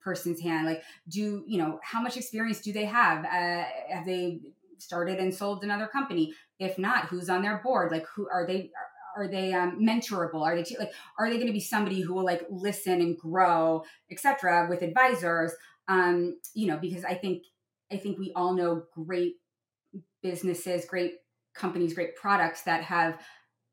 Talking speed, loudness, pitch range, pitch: 180 wpm, -29 LUFS, 175-205 Hz, 180 Hz